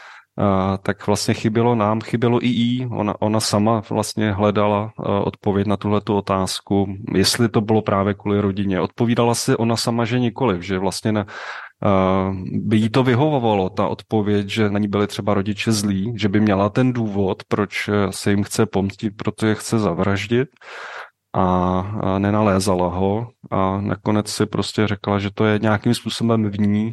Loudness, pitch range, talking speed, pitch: -20 LUFS, 100-115 Hz, 170 wpm, 105 Hz